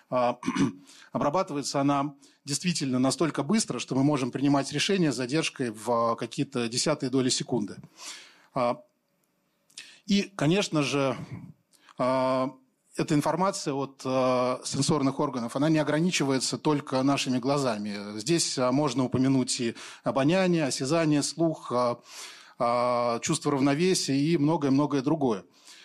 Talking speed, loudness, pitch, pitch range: 100 wpm, -27 LUFS, 140 Hz, 130-155 Hz